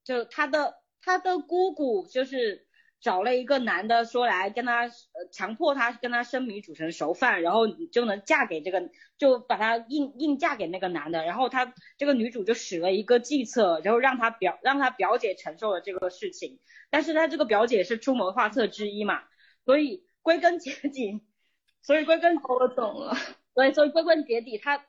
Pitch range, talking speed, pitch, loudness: 215-300 Hz, 280 characters per minute, 250 Hz, -26 LUFS